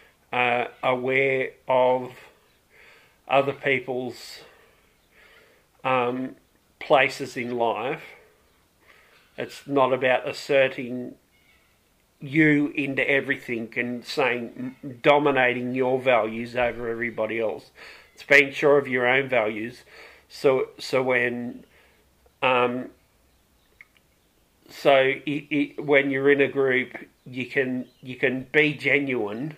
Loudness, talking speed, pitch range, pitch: -23 LUFS, 95 wpm, 125-140 Hz, 130 Hz